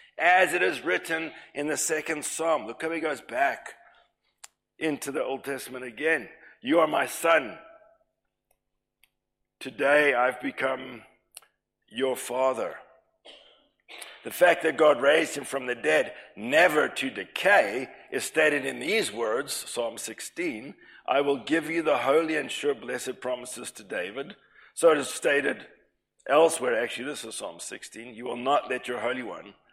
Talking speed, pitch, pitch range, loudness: 150 wpm, 145 Hz, 130-160 Hz, -26 LUFS